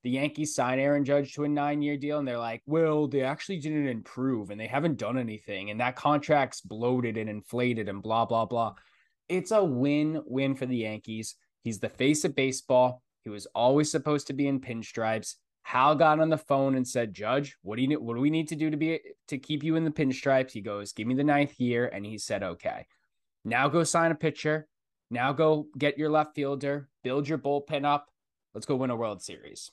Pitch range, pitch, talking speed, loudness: 120-150 Hz, 140 Hz, 220 wpm, -28 LUFS